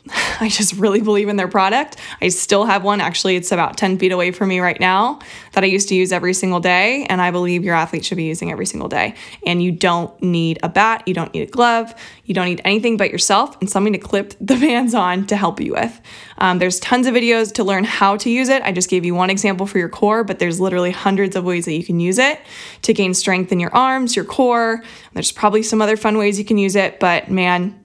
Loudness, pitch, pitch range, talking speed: -16 LUFS, 195 Hz, 180-215 Hz, 255 wpm